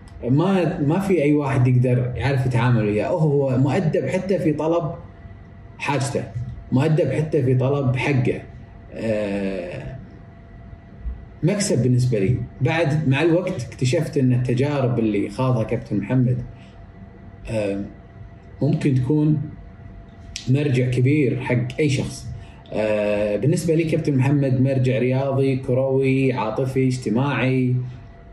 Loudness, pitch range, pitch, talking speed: -21 LUFS, 110-140 Hz, 130 Hz, 110 wpm